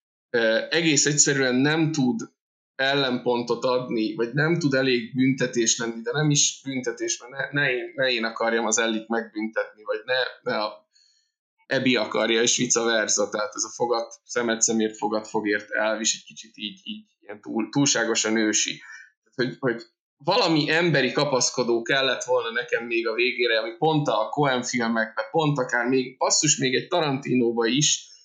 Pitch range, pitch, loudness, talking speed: 115-155 Hz, 125 Hz, -23 LUFS, 165 wpm